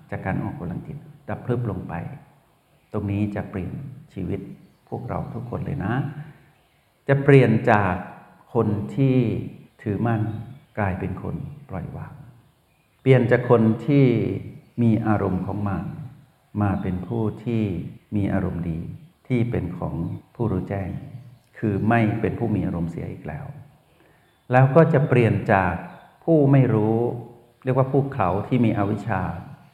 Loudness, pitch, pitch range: -23 LUFS, 115 Hz, 105-135 Hz